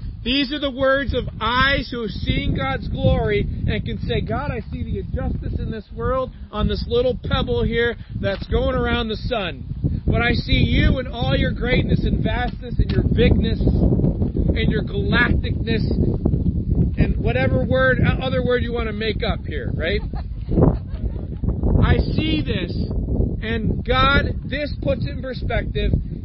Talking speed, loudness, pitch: 160 wpm, -21 LUFS, 230 Hz